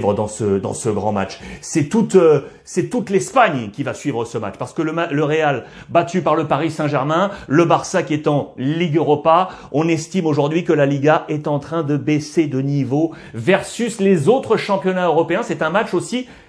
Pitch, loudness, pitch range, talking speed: 160 Hz, -18 LUFS, 145-175 Hz, 205 wpm